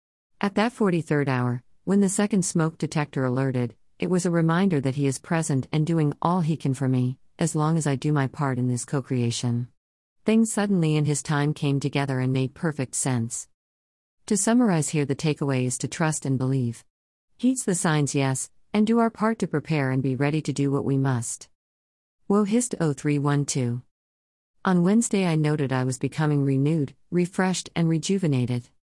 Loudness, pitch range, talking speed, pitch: -24 LUFS, 130-165 Hz, 180 wpm, 145 Hz